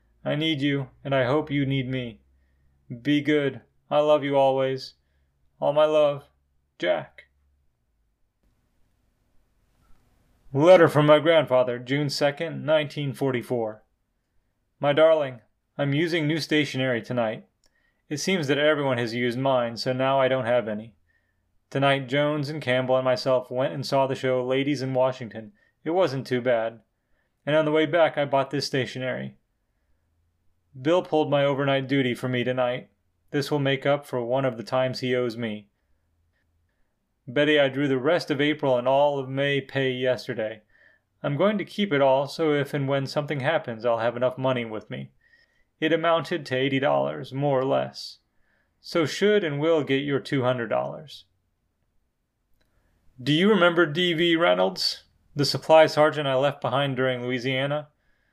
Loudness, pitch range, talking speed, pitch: -24 LUFS, 120-145 Hz, 160 wpm, 135 Hz